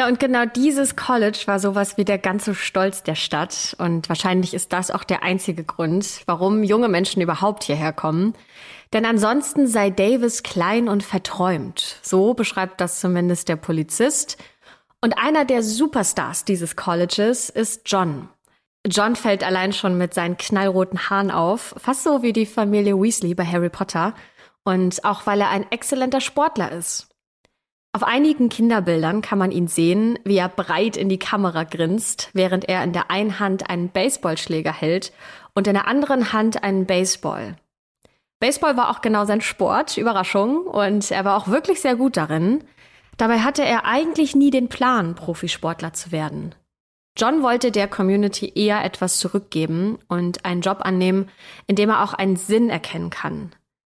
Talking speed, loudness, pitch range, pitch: 165 wpm, -20 LUFS, 180-230 Hz, 200 Hz